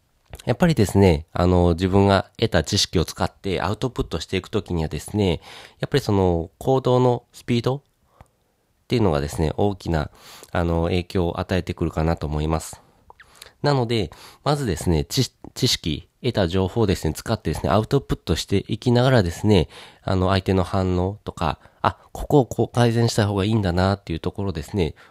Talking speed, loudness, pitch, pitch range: 370 characters per minute, -22 LUFS, 95 Hz, 85-115 Hz